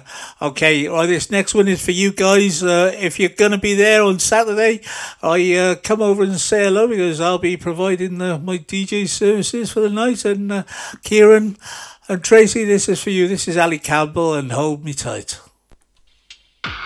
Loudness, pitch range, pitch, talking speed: -16 LUFS, 170-210 Hz, 190 Hz, 185 wpm